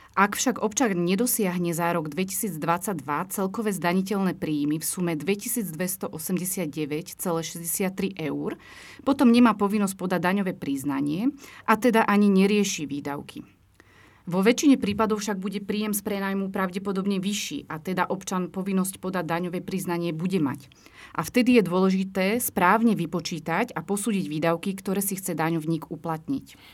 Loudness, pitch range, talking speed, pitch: -25 LUFS, 170-205 Hz, 130 wpm, 190 Hz